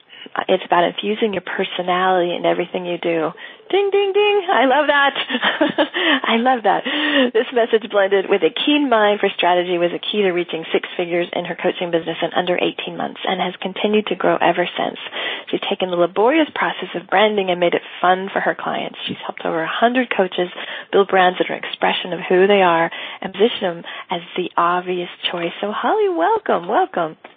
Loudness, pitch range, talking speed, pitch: -18 LUFS, 180-250 Hz, 195 wpm, 195 Hz